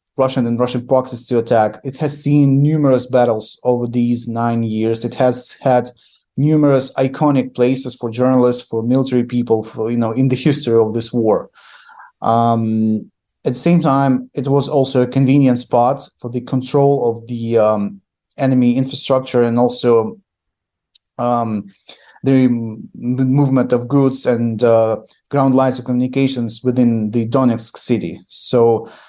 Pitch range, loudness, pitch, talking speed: 115-130 Hz, -16 LUFS, 125 Hz, 155 wpm